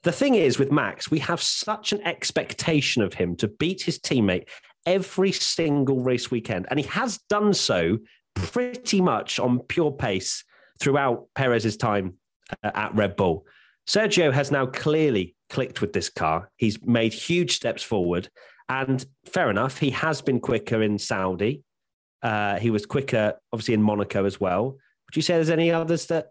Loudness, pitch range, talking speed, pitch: -24 LUFS, 110-170 Hz, 170 wpm, 135 Hz